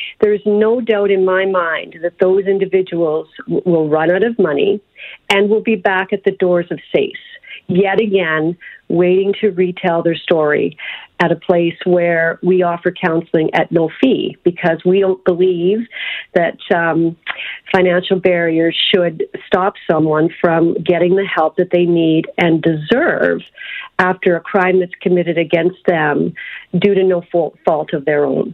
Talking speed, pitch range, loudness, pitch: 160 wpm, 170-195 Hz, -15 LUFS, 180 Hz